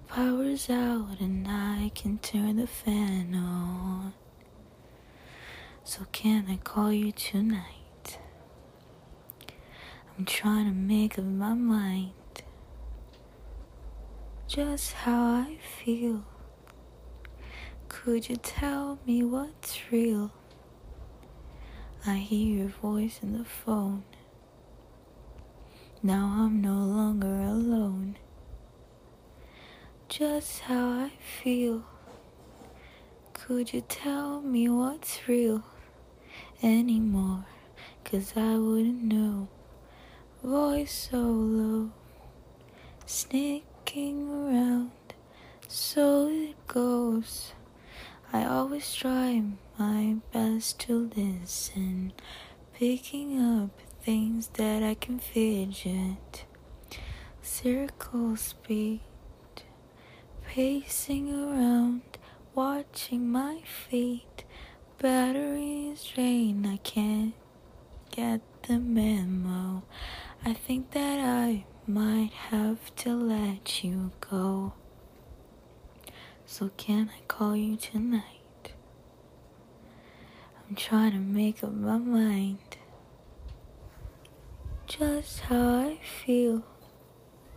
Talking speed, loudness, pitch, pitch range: 85 wpm, -30 LUFS, 220 Hz, 195-245 Hz